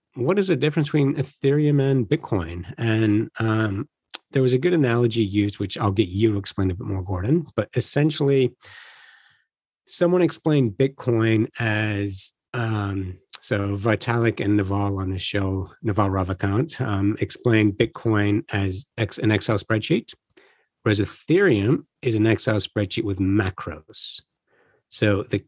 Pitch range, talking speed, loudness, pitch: 100-130 Hz, 140 wpm, -23 LUFS, 110 Hz